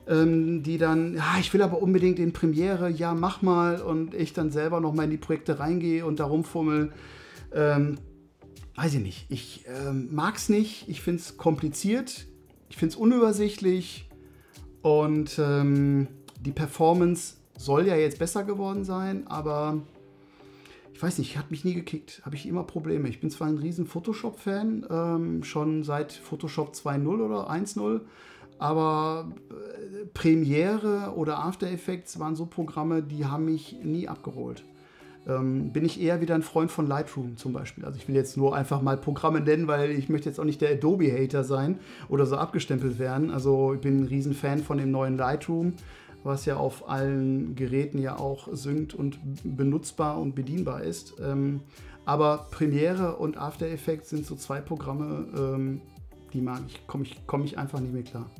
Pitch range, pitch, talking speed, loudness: 135-165 Hz, 150 Hz, 170 wpm, -28 LUFS